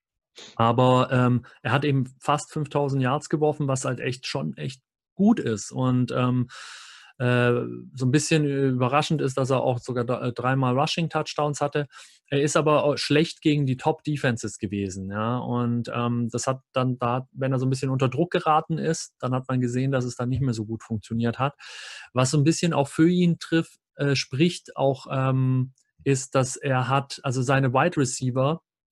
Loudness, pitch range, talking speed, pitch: -24 LUFS, 125-150 Hz, 190 wpm, 130 Hz